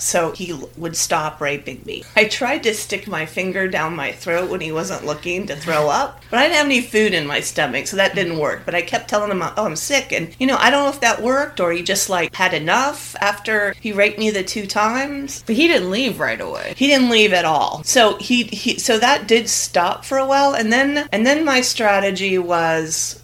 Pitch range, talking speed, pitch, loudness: 175-245 Hz, 240 wpm, 205 Hz, -17 LUFS